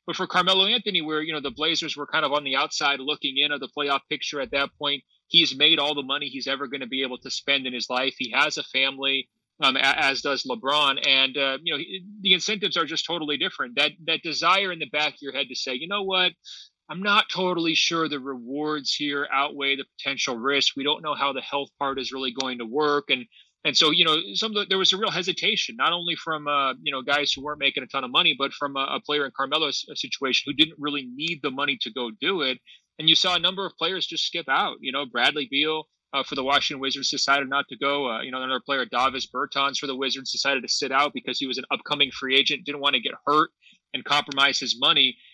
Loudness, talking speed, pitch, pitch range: -23 LUFS, 255 wpm, 145 Hz, 135-160 Hz